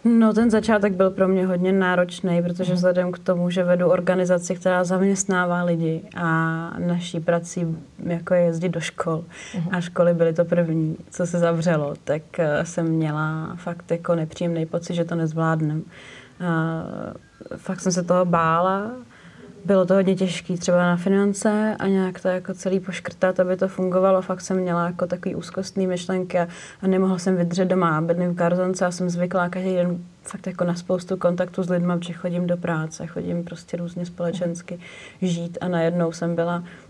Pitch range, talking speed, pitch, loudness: 170-185 Hz, 170 wpm, 180 Hz, -22 LUFS